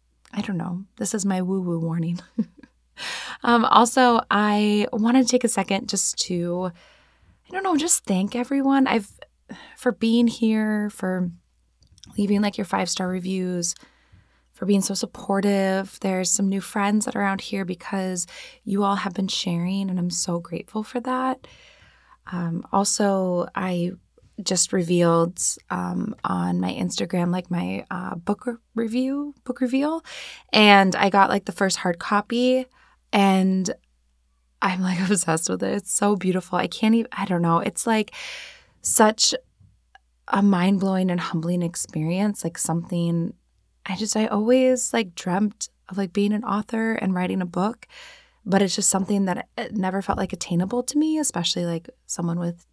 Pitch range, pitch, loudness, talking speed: 180-225 Hz, 195 Hz, -23 LUFS, 160 wpm